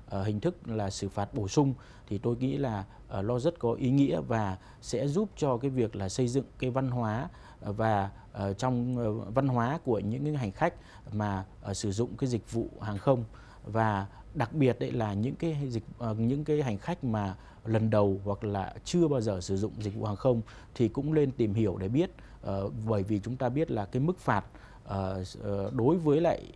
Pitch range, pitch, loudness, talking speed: 105-130 Hz, 115 Hz, -31 LUFS, 200 wpm